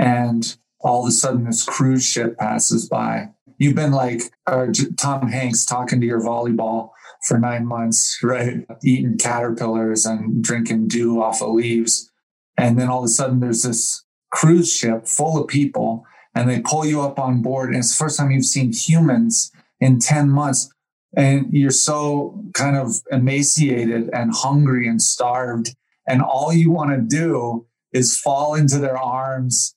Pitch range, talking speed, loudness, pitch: 115-140 Hz, 165 wpm, -18 LUFS, 125 Hz